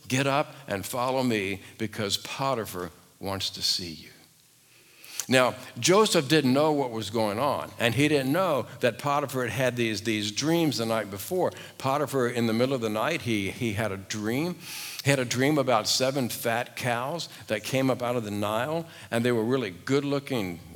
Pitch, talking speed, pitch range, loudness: 125 Hz, 190 wpm, 110-140 Hz, -27 LUFS